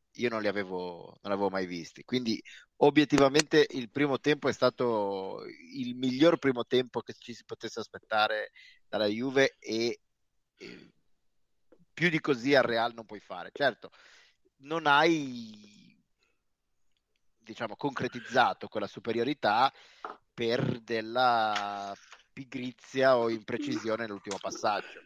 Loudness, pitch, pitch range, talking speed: -29 LUFS, 120 Hz, 110-140 Hz, 115 wpm